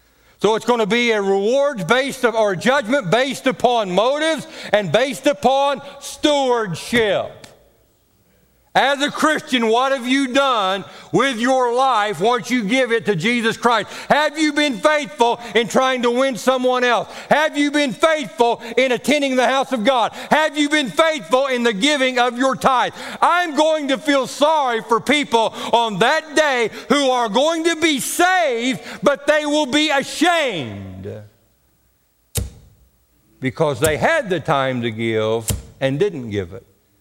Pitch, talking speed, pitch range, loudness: 245 Hz, 155 wpm, 210-280 Hz, -18 LUFS